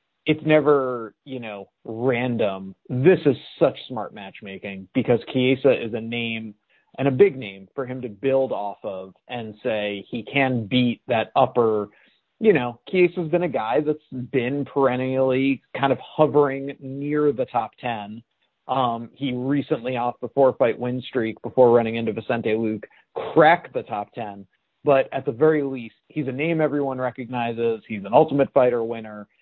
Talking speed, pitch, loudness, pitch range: 165 wpm, 125 Hz, -22 LUFS, 115-140 Hz